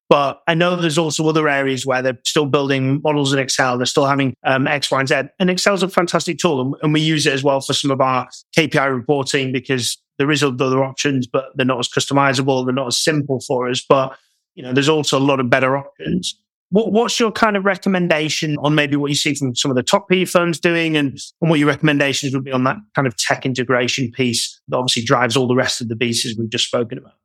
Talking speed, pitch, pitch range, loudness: 245 wpm, 140 Hz, 130-155 Hz, -17 LUFS